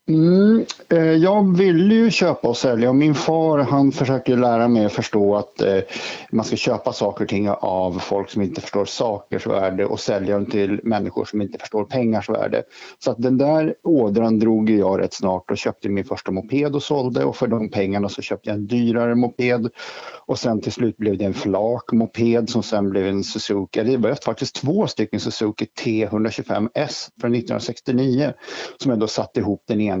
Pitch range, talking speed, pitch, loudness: 100-130 Hz, 190 wpm, 115 Hz, -20 LUFS